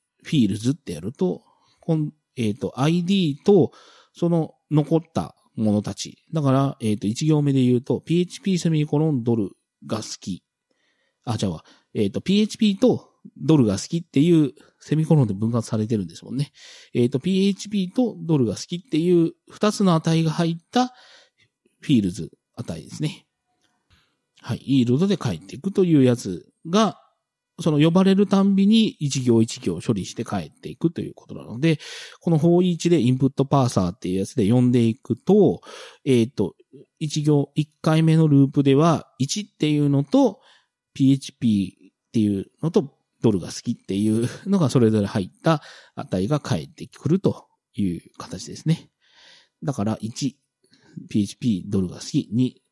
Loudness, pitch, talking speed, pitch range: -22 LUFS, 150 Hz, 315 characters per minute, 120-170 Hz